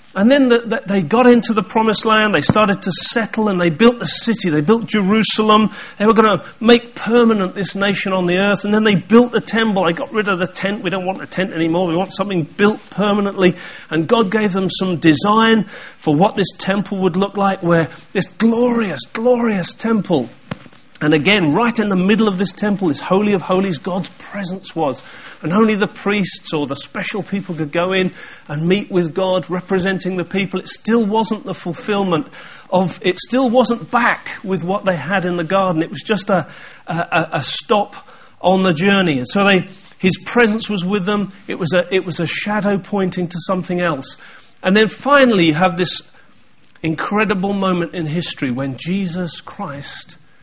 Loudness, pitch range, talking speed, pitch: -16 LUFS, 180-215 Hz, 200 wpm, 195 Hz